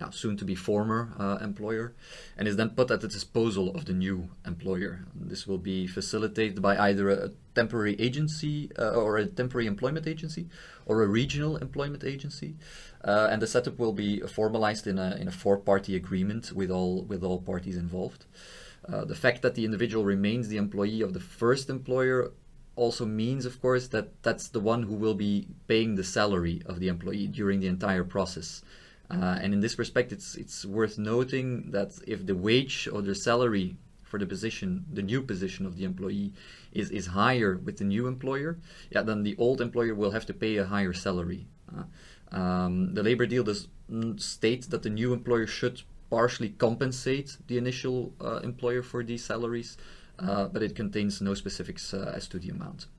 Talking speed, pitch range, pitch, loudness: 190 wpm, 100-125 Hz, 110 Hz, -30 LUFS